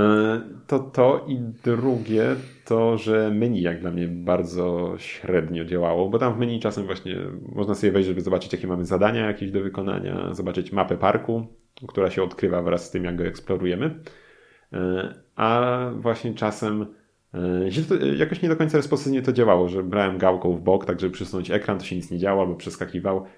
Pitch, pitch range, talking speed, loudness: 95 Hz, 90-115 Hz, 175 wpm, -24 LUFS